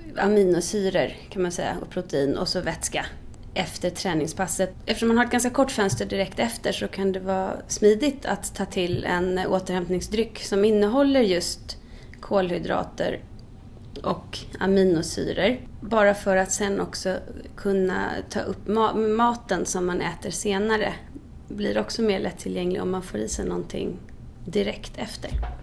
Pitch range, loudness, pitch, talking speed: 180-210 Hz, -25 LUFS, 190 Hz, 145 wpm